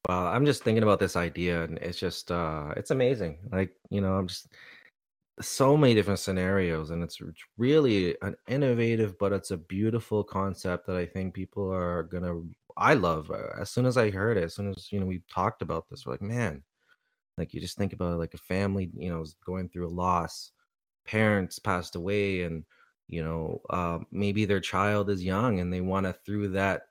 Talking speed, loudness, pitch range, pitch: 205 wpm, -29 LUFS, 90-100 Hz, 95 Hz